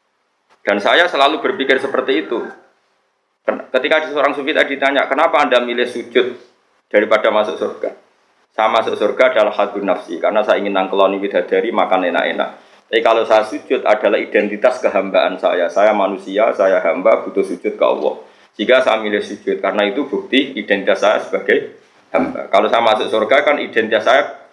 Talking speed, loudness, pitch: 160 wpm, -16 LUFS, 155 Hz